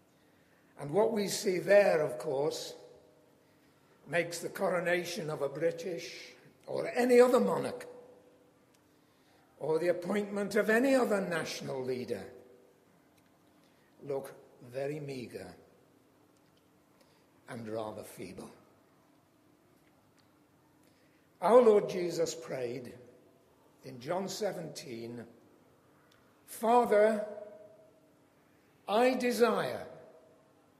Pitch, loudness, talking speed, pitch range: 175 Hz, -31 LUFS, 80 wpm, 150-215 Hz